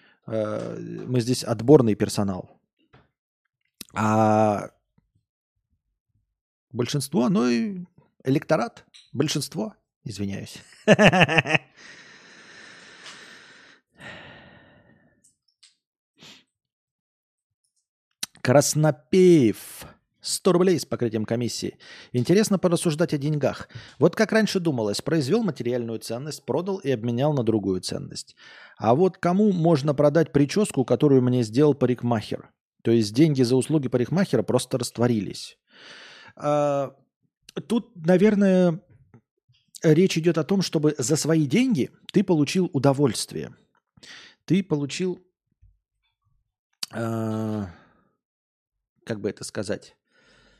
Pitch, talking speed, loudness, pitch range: 145 Hz, 85 wpm, -23 LUFS, 115-175 Hz